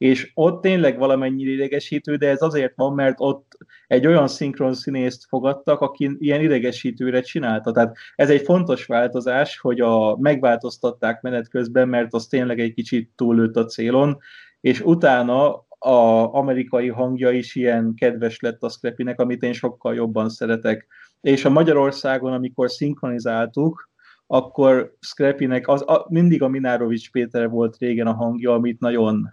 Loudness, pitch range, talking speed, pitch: -20 LUFS, 120-140 Hz, 150 wpm, 125 Hz